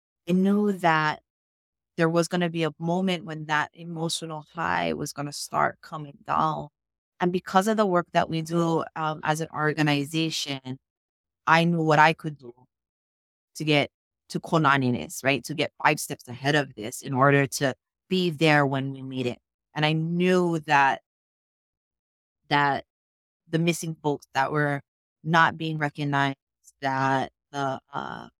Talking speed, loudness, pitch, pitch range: 160 wpm, -25 LUFS, 150 Hz, 135-165 Hz